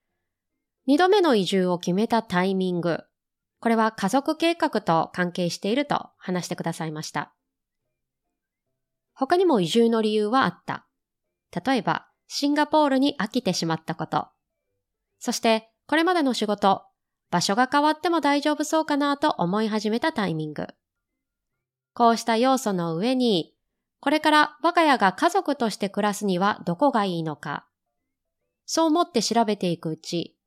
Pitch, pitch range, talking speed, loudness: 215 Hz, 175-285 Hz, 300 characters per minute, -23 LUFS